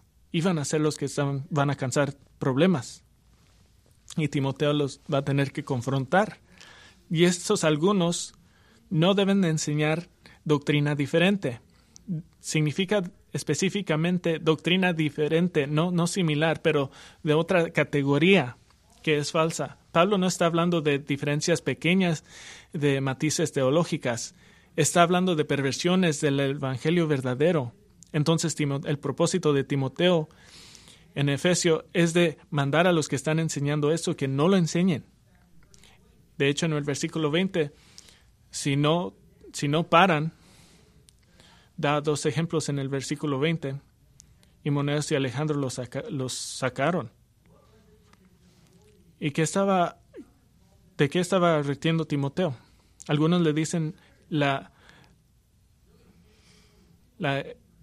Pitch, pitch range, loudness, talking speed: 150 Hz, 140-170 Hz, -25 LUFS, 120 wpm